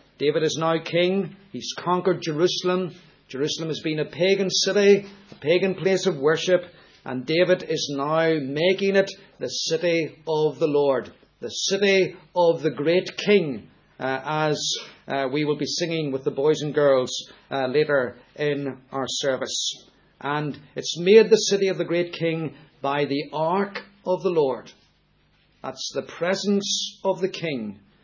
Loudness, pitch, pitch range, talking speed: -23 LUFS, 165 Hz, 145-185 Hz, 155 wpm